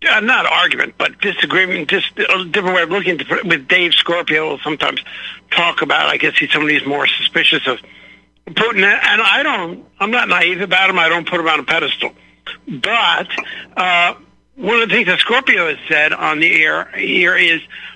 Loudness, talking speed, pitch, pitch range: -13 LUFS, 200 wpm, 180 Hz, 165-190 Hz